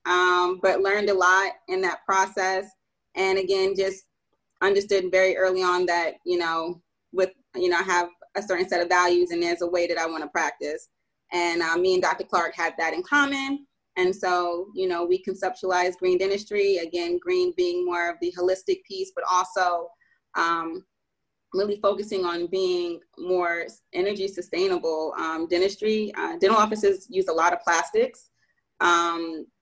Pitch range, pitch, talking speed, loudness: 175-200 Hz, 185 Hz, 170 wpm, -24 LUFS